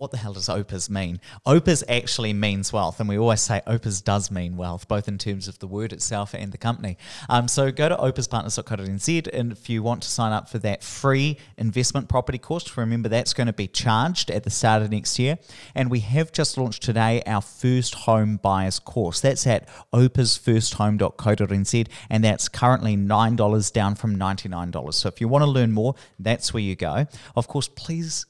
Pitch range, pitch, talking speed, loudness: 105-125 Hz, 115 Hz, 205 wpm, -23 LUFS